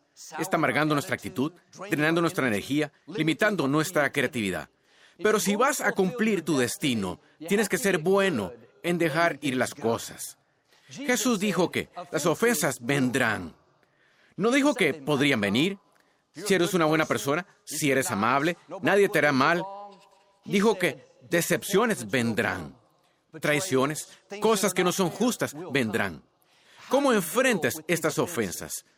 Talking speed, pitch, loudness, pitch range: 135 wpm, 170 Hz, -26 LUFS, 150-200 Hz